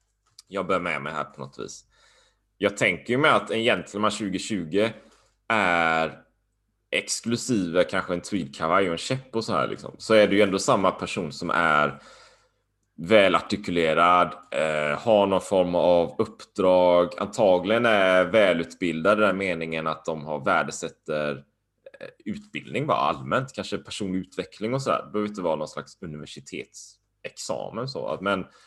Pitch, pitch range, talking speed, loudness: 95 Hz, 80-110 Hz, 155 wpm, -24 LUFS